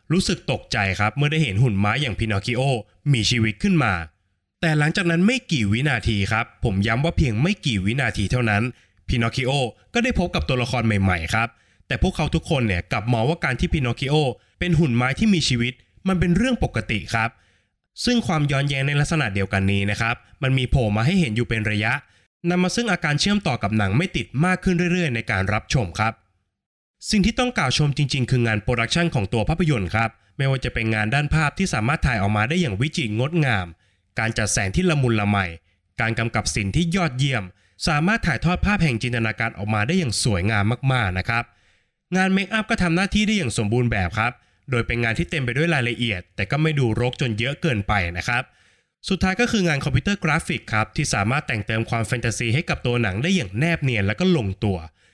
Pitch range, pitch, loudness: 105-160 Hz, 125 Hz, -22 LUFS